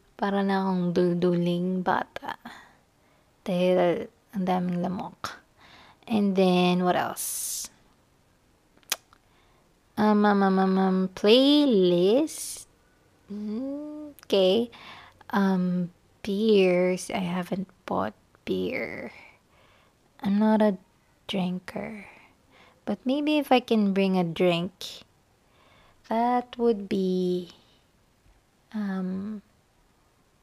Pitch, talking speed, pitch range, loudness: 195 Hz, 80 wpm, 180-215 Hz, -25 LUFS